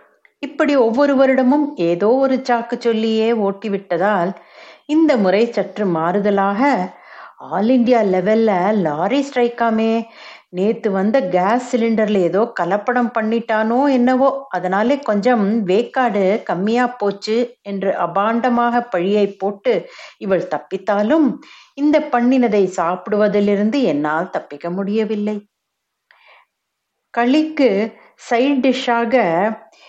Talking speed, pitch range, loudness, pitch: 90 wpm, 200-255 Hz, -17 LUFS, 225 Hz